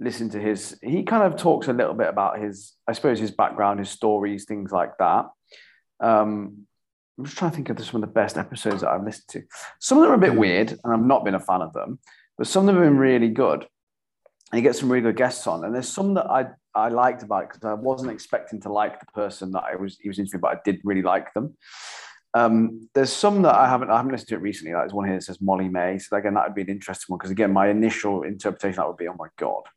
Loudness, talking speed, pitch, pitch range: -23 LUFS, 270 wpm, 105 Hz, 100-120 Hz